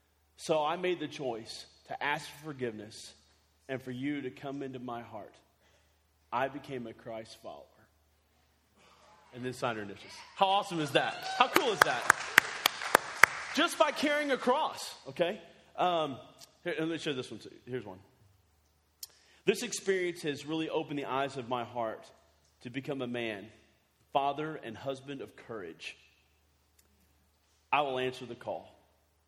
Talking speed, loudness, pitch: 155 wpm, -32 LUFS, 120 Hz